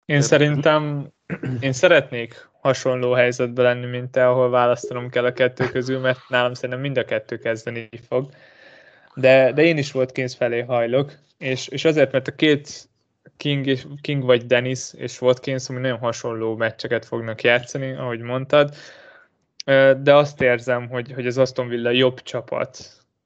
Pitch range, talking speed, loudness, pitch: 125-135 Hz, 155 wpm, -20 LUFS, 130 Hz